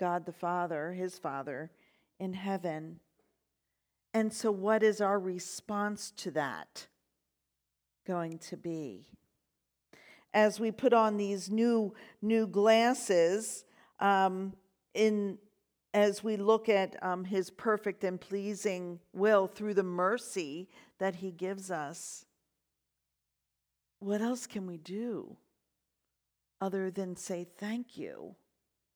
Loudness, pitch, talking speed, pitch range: -32 LUFS, 190 Hz, 115 wpm, 175-215 Hz